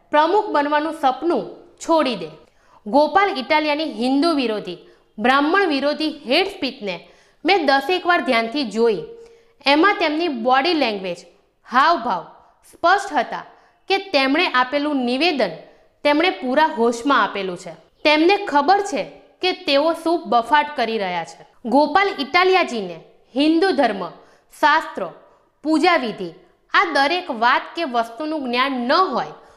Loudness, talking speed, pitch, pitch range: -19 LUFS, 120 wpm, 295 Hz, 245-345 Hz